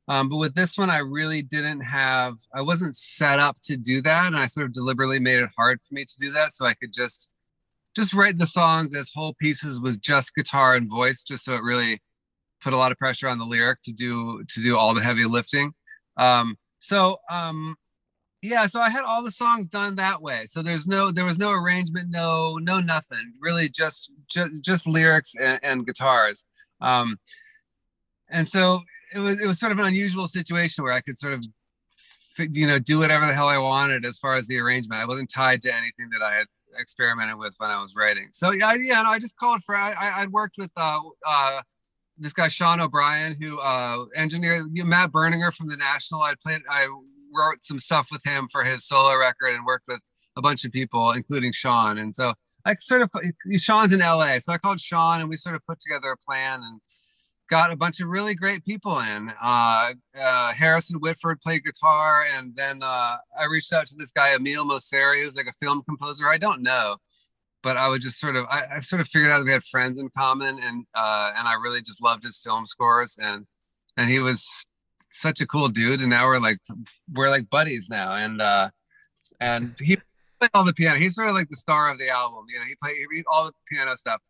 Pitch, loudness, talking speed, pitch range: 145 Hz, -22 LUFS, 225 wpm, 130-170 Hz